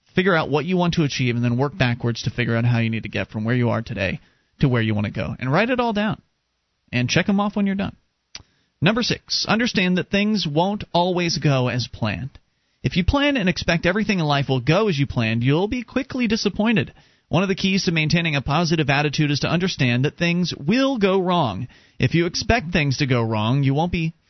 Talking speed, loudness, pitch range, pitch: 235 wpm, -21 LUFS, 125-195 Hz, 160 Hz